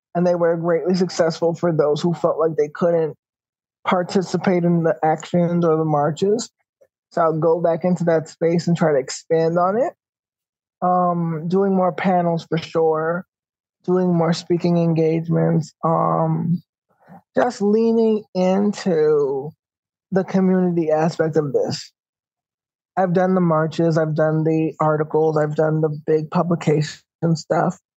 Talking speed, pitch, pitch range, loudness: 140 wpm, 170 Hz, 160-180 Hz, -19 LUFS